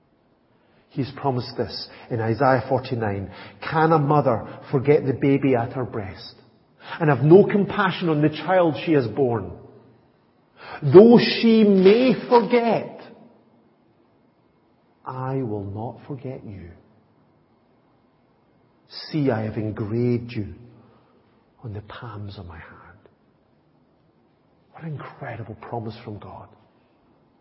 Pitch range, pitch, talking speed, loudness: 110-150 Hz, 130 Hz, 110 wpm, -20 LUFS